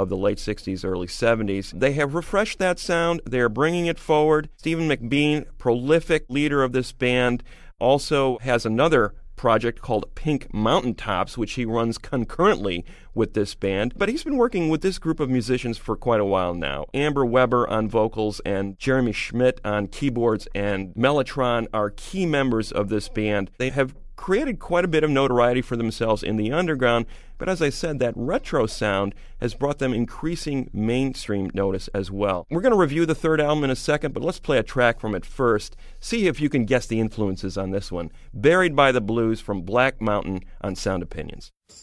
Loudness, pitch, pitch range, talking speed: -23 LUFS, 120 Hz, 105-145 Hz, 195 wpm